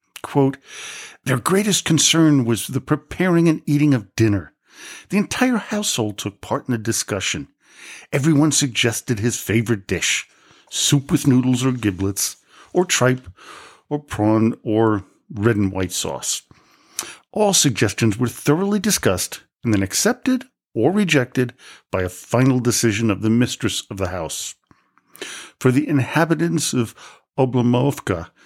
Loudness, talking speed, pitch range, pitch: -19 LUFS, 135 wpm, 110-155 Hz, 125 Hz